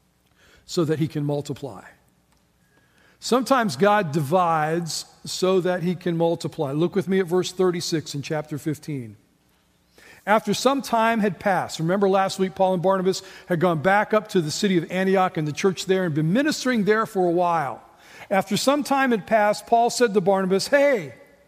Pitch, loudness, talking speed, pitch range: 185 Hz, -22 LUFS, 175 wpm, 160-210 Hz